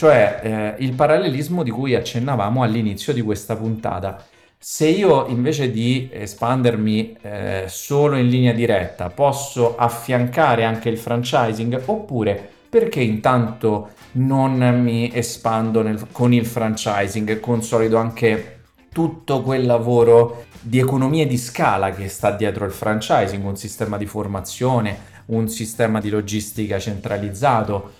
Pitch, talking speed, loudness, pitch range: 115 Hz, 130 wpm, -19 LUFS, 105-125 Hz